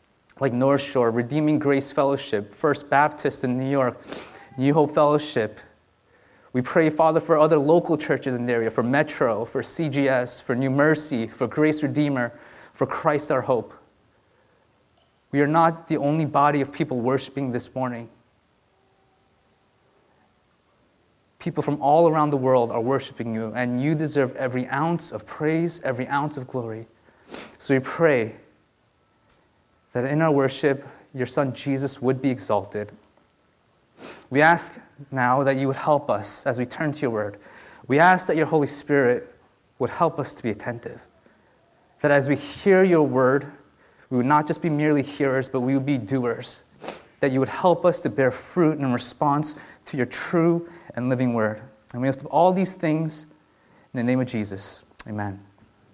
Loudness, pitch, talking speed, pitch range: -23 LUFS, 140 Hz, 165 wpm, 125-150 Hz